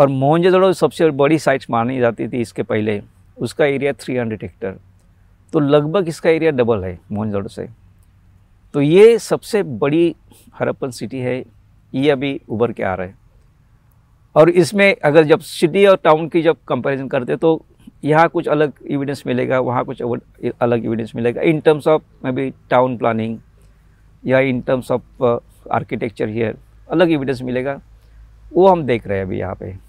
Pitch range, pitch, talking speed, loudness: 115-155 Hz, 130 Hz, 170 wpm, -17 LUFS